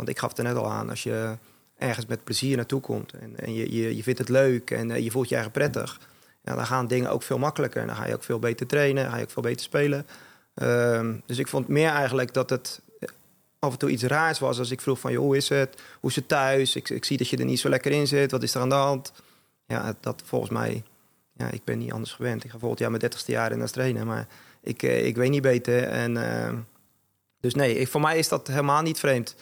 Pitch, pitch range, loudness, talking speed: 130 Hz, 115-135 Hz, -26 LUFS, 265 wpm